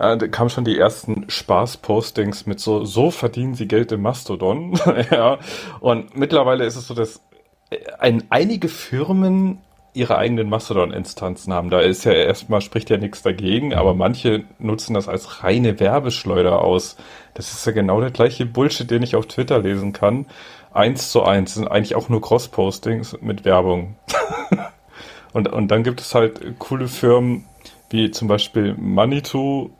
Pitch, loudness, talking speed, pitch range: 115 Hz, -19 LUFS, 160 wpm, 105-125 Hz